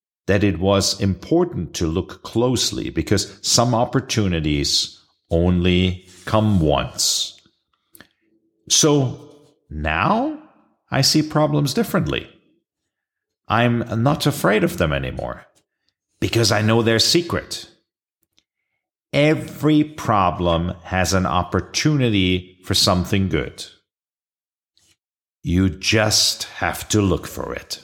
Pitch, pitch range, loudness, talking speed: 105 Hz, 90-140 Hz, -19 LUFS, 95 wpm